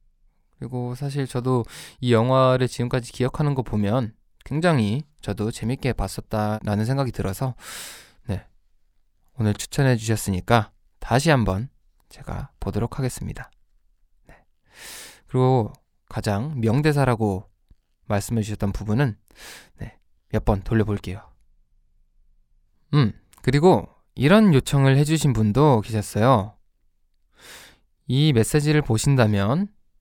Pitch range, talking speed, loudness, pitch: 100-130 Hz, 240 characters per minute, -22 LUFS, 110 Hz